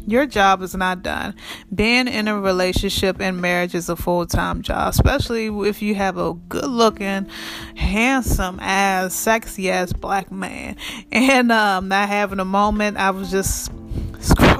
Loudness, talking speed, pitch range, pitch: -19 LUFS, 165 wpm, 185-215 Hz, 195 Hz